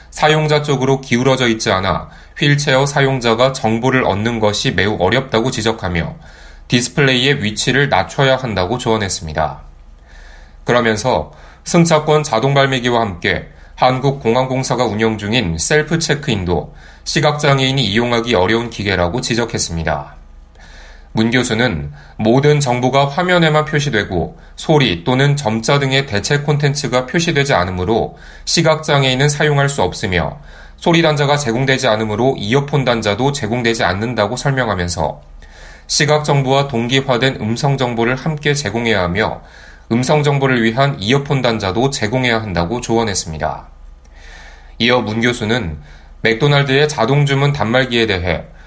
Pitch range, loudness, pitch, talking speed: 95-140 Hz, -15 LUFS, 120 Hz, 330 characters per minute